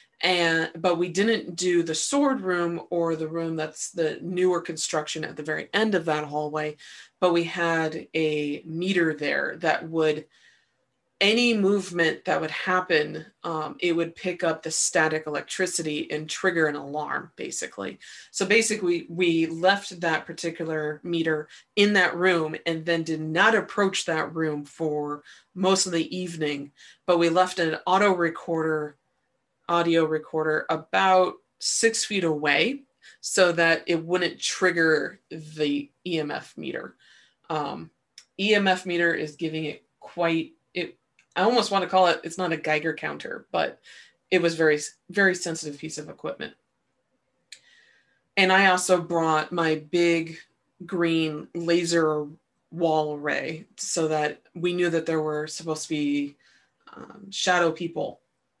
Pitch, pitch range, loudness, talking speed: 165 Hz, 155-180 Hz, -25 LUFS, 145 wpm